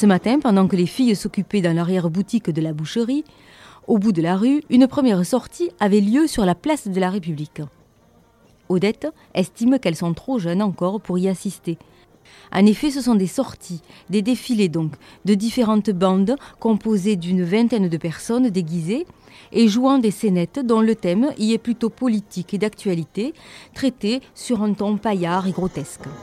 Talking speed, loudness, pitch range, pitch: 175 wpm, -20 LUFS, 180-235 Hz, 210 Hz